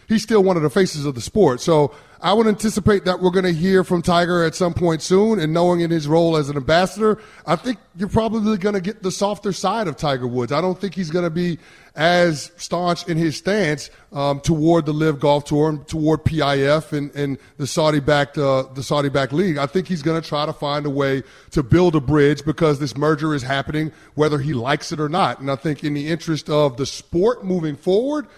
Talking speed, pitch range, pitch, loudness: 235 wpm, 145-185 Hz, 160 Hz, -19 LUFS